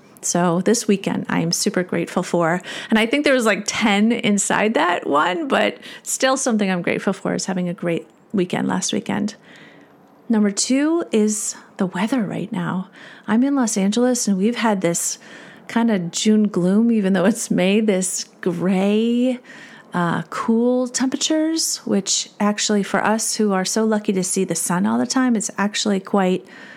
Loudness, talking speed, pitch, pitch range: -19 LUFS, 175 wpm, 215 Hz, 190-240 Hz